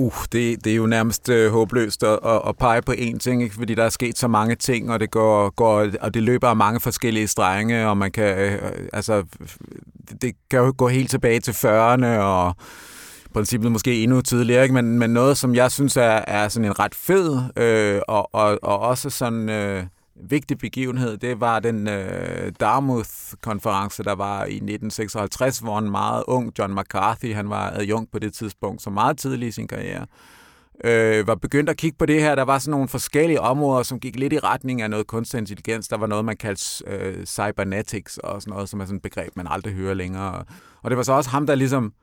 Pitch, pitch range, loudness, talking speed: 115 Hz, 105-125 Hz, -21 LUFS, 215 wpm